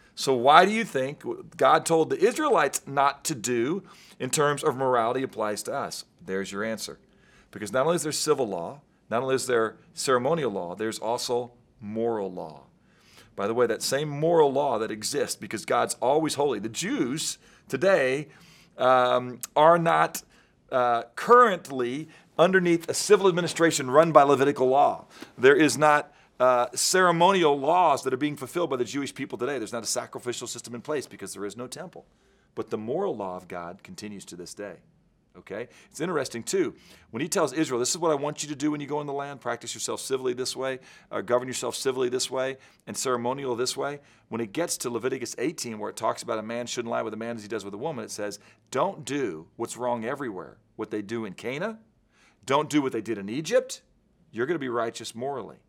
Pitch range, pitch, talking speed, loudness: 115-155 Hz, 130 Hz, 205 wpm, -26 LUFS